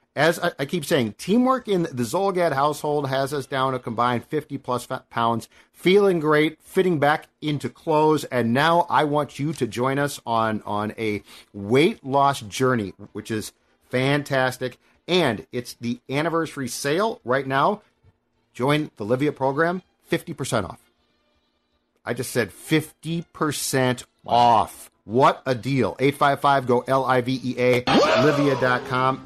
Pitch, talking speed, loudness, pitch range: 135 Hz, 145 wpm, -22 LUFS, 120-150 Hz